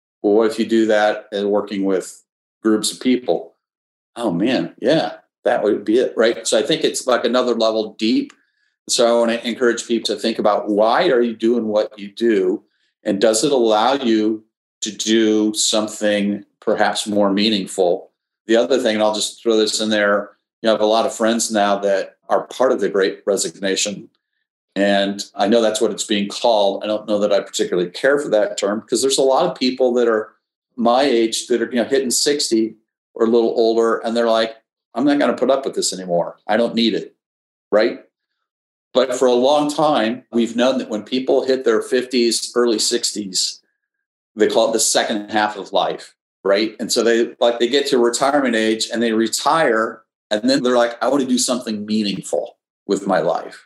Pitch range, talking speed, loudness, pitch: 105-125 Hz, 205 wpm, -18 LUFS, 115 Hz